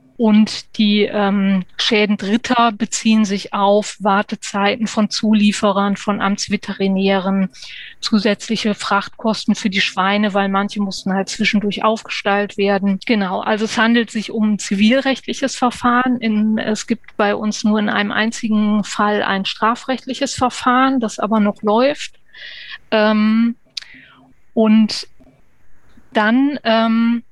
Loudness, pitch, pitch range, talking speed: -17 LUFS, 215 Hz, 200-225 Hz, 120 wpm